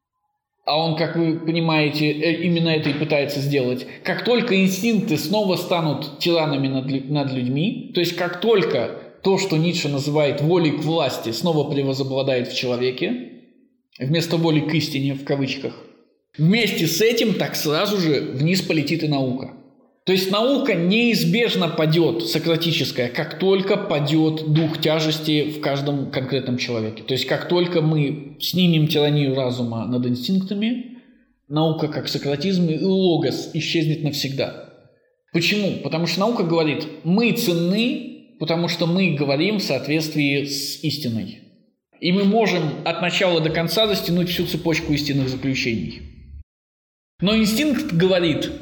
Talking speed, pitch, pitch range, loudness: 140 wpm, 160 Hz, 145-190 Hz, -20 LUFS